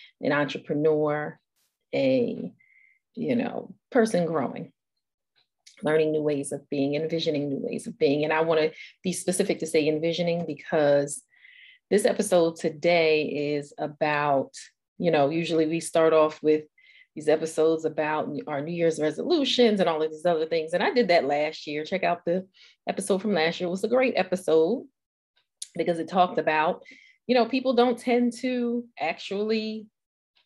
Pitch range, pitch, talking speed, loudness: 155-225 Hz, 165 Hz, 160 wpm, -25 LUFS